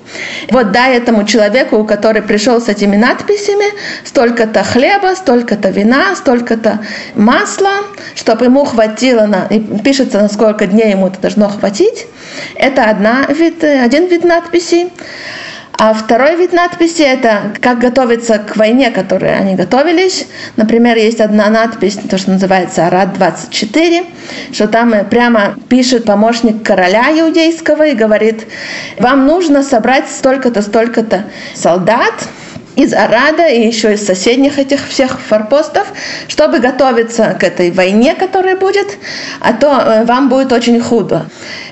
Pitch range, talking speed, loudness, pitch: 215-290 Hz, 130 wpm, -10 LUFS, 240 Hz